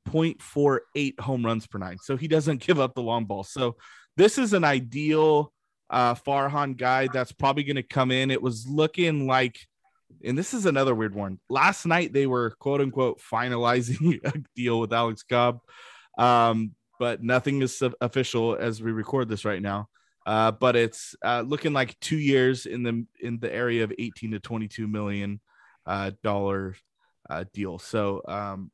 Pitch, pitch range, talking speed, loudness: 120 Hz, 110-140 Hz, 175 wpm, -26 LUFS